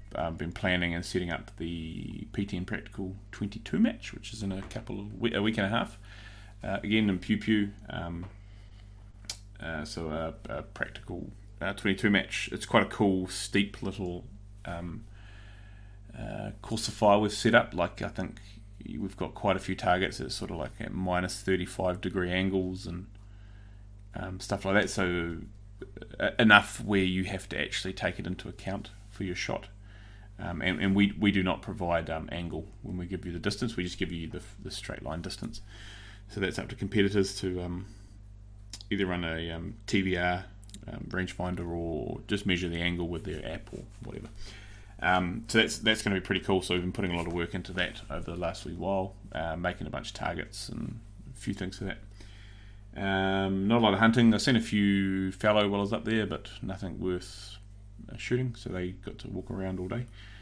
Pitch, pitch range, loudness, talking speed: 100 Hz, 90-105 Hz, -31 LUFS, 200 wpm